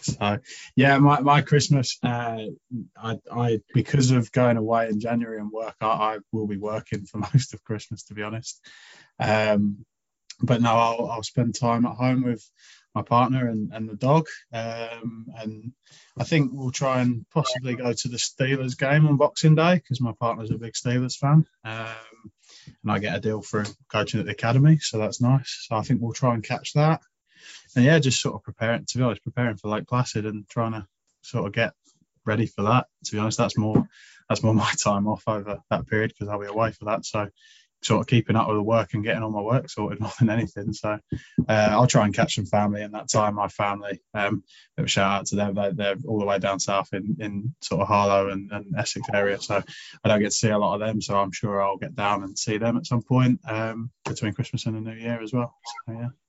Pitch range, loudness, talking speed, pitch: 105-125 Hz, -24 LUFS, 230 wpm, 115 Hz